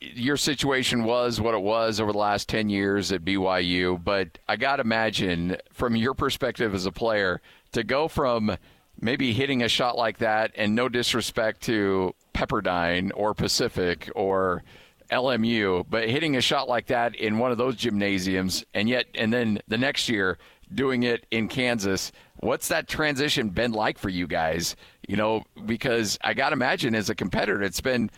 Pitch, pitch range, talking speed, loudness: 110 Hz, 95-120 Hz, 180 wpm, -25 LUFS